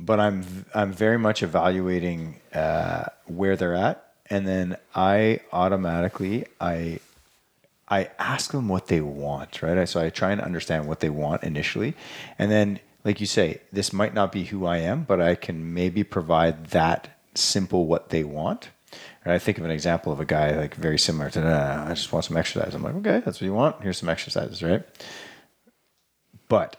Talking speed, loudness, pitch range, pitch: 190 wpm, -25 LUFS, 80-100 Hz, 90 Hz